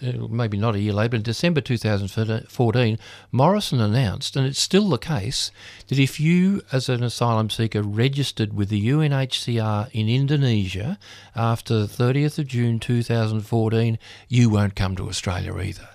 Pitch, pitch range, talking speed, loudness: 115 Hz, 105-130 Hz, 155 wpm, -22 LUFS